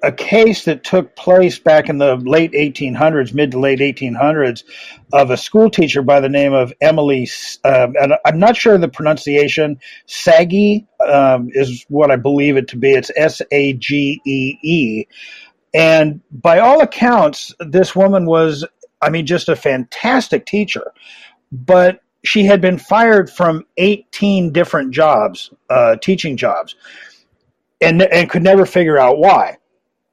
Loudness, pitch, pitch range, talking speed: -13 LUFS, 160 Hz, 140-190 Hz, 155 wpm